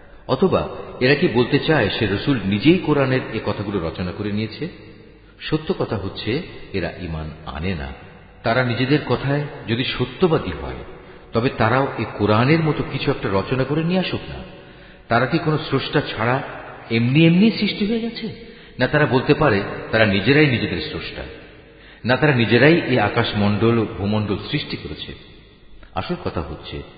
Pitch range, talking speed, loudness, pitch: 100-150 Hz, 150 wpm, -20 LUFS, 120 Hz